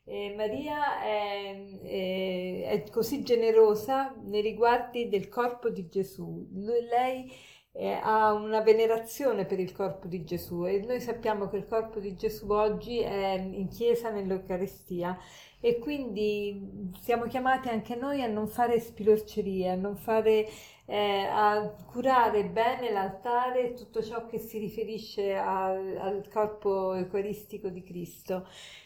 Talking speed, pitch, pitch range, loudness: 135 wpm, 215 Hz, 195-230 Hz, -30 LUFS